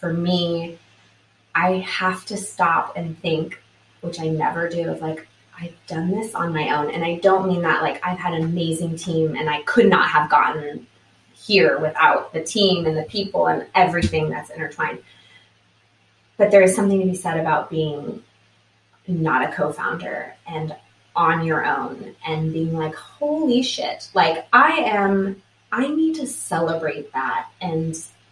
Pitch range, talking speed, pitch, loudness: 150-185 Hz, 165 wpm, 165 Hz, -20 LUFS